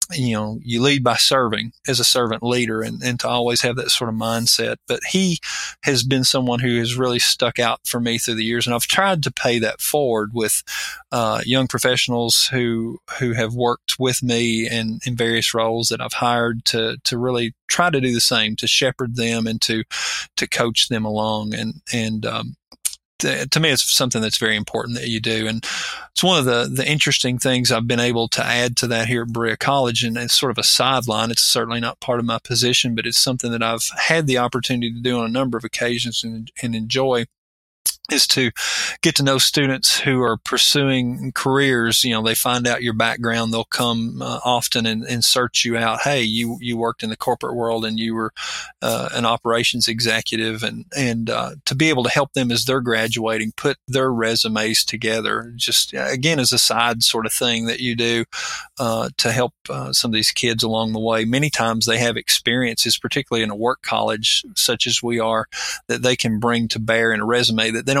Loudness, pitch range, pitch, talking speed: -19 LUFS, 115-125 Hz, 120 Hz, 215 wpm